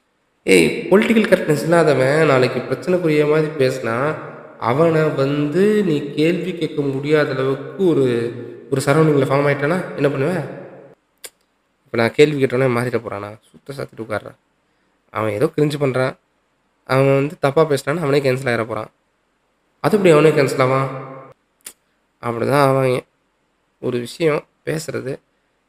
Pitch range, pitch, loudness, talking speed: 130-155 Hz, 140 Hz, -18 LUFS, 125 wpm